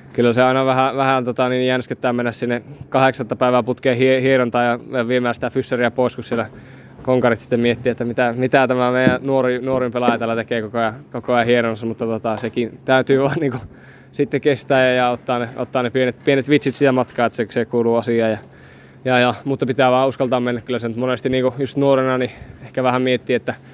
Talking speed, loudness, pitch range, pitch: 210 wpm, -18 LUFS, 120-130 Hz, 125 Hz